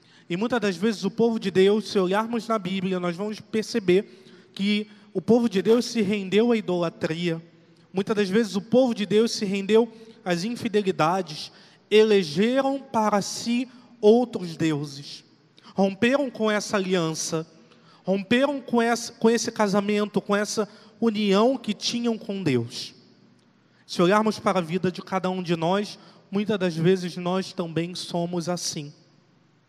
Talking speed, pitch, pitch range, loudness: 145 wpm, 200 Hz, 180-225 Hz, -24 LUFS